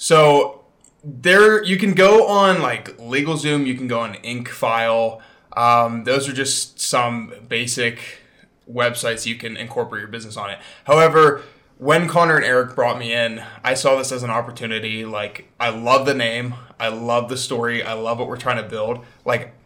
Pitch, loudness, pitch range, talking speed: 120 Hz, -18 LUFS, 115-140 Hz, 175 wpm